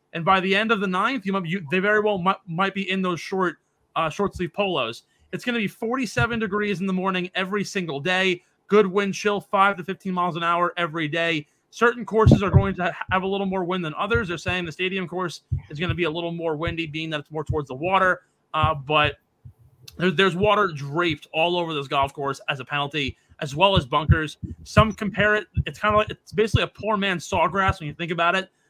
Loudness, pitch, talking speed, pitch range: -23 LUFS, 180 Hz, 240 wpm, 155-195 Hz